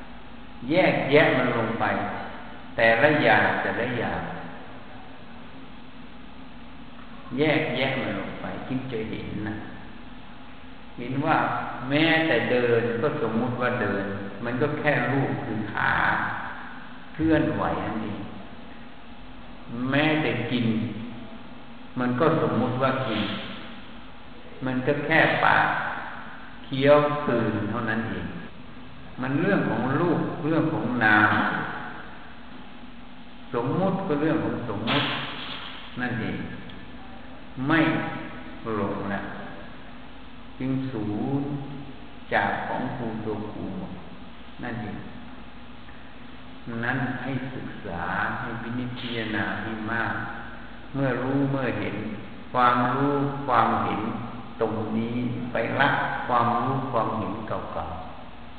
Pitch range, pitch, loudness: 110-140 Hz, 120 Hz, -25 LUFS